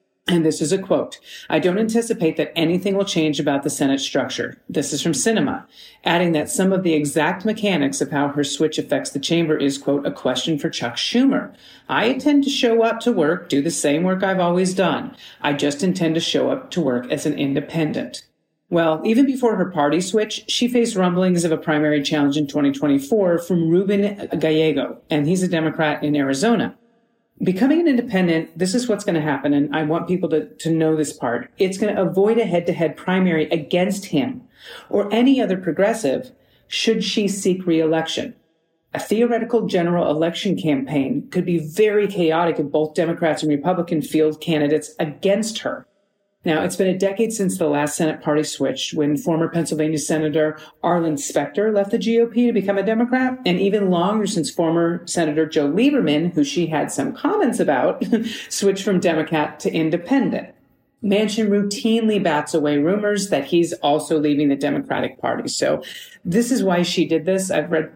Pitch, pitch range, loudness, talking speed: 170 Hz, 155-205 Hz, -20 LUFS, 185 wpm